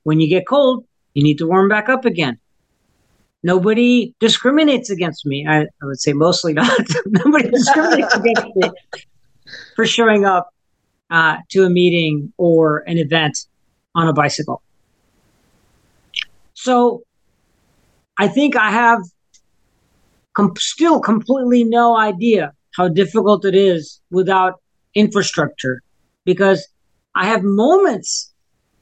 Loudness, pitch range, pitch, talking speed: -15 LUFS, 165-235 Hz, 195 Hz, 120 wpm